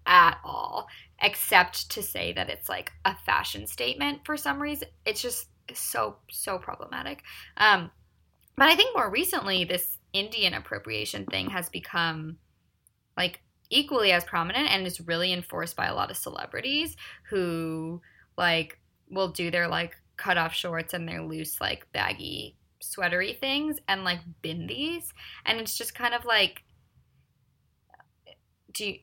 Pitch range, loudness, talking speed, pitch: 170-240 Hz, -27 LUFS, 145 wpm, 180 Hz